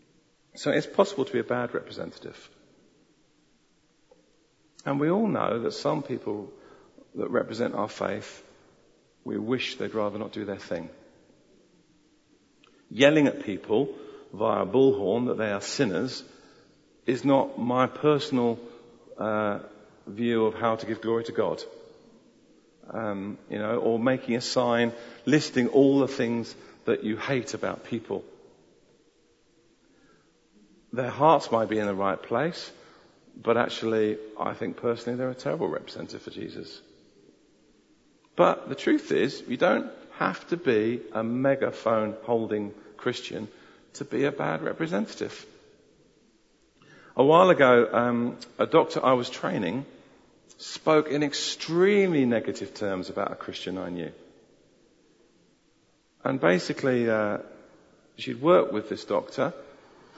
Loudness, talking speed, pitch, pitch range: -26 LUFS, 130 wpm, 120 Hz, 110-135 Hz